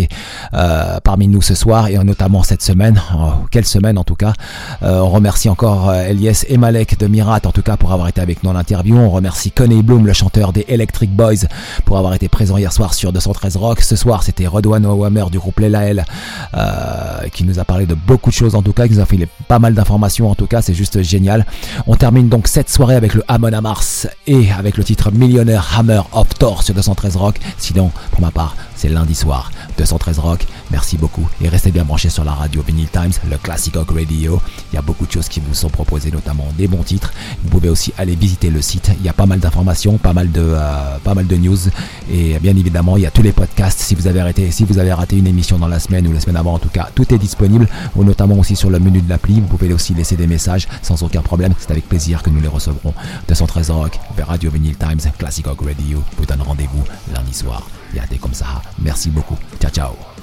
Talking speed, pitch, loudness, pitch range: 240 wpm, 95 Hz, -14 LUFS, 85-105 Hz